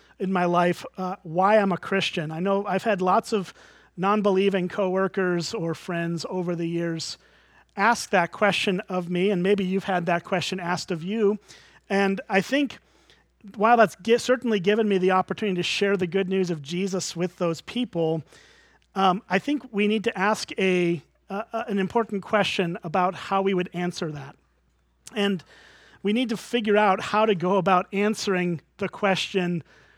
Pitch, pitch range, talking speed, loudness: 190 Hz, 175-205 Hz, 175 wpm, -24 LUFS